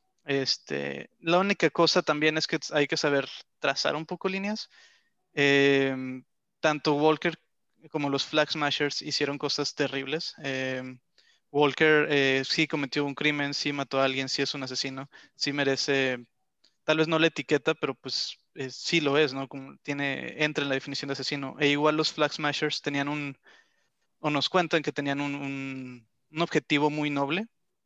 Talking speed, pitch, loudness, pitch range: 170 wpm, 145 Hz, -27 LUFS, 135-155 Hz